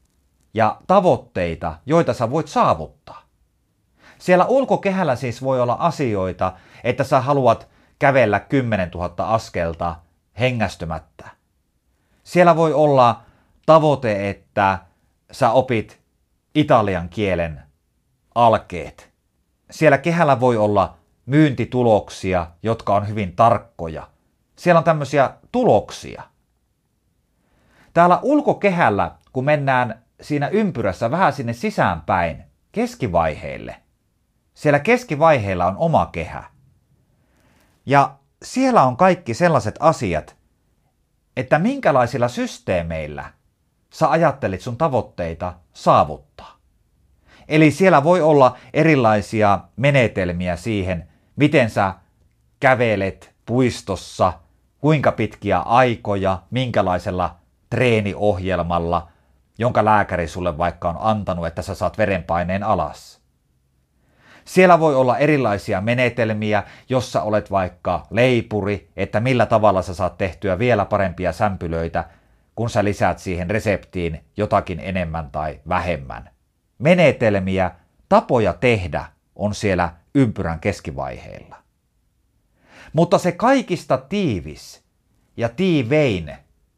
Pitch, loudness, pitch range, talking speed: 105 Hz, -19 LUFS, 85-130 Hz, 95 wpm